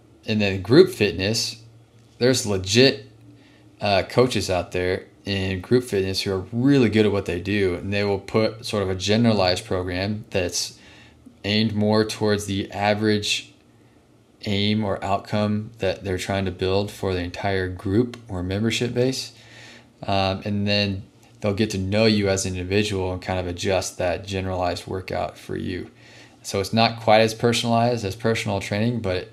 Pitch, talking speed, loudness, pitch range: 105 Hz, 170 wpm, -22 LUFS, 95-110 Hz